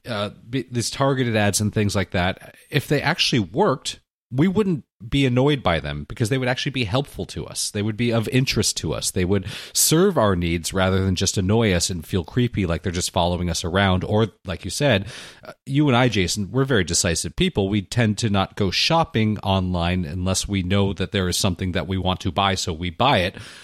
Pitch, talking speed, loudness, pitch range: 100 Hz, 220 wpm, -21 LUFS, 95-120 Hz